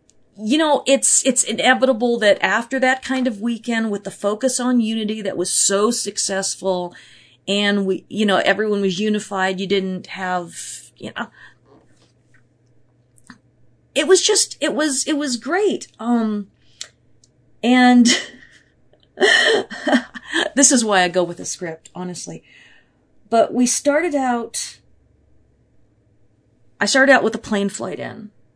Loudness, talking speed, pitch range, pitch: -18 LUFS, 130 wpm, 190-260 Hz, 215 Hz